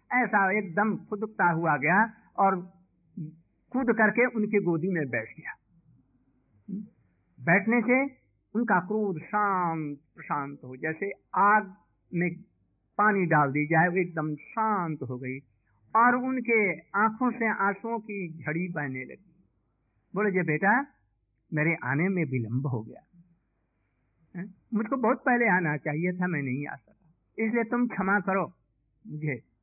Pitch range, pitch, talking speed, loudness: 145-210 Hz, 175 Hz, 130 wpm, -27 LUFS